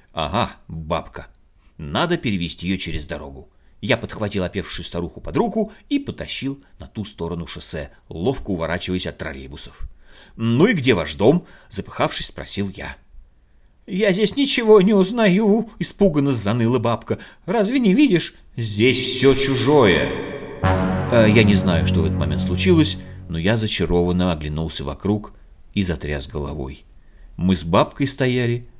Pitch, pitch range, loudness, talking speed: 95 Hz, 80-130 Hz, -20 LUFS, 135 wpm